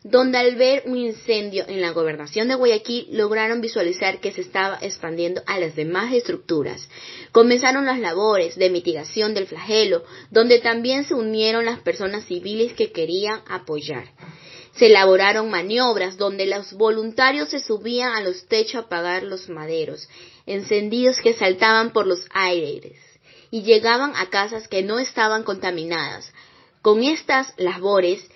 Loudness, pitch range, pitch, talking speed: -20 LUFS, 185-230 Hz, 215 Hz, 145 wpm